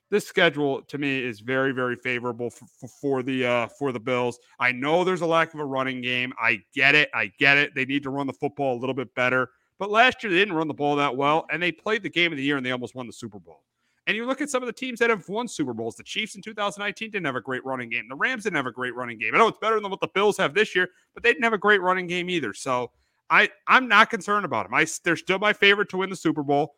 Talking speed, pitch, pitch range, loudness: 300 wpm, 145 Hz, 130-200 Hz, -23 LUFS